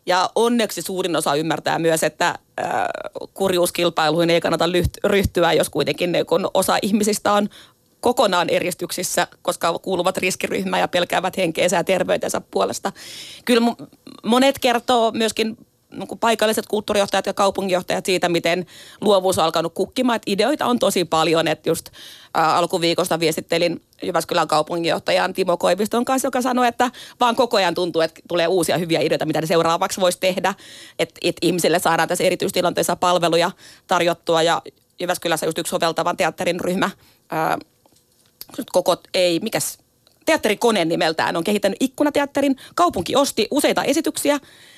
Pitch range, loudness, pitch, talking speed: 170-225 Hz, -20 LUFS, 185 Hz, 135 wpm